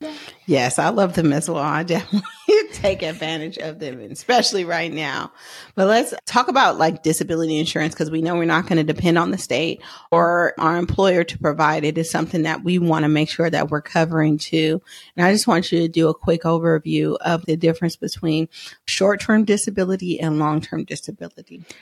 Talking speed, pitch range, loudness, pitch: 200 wpm, 160-175 Hz, -19 LUFS, 165 Hz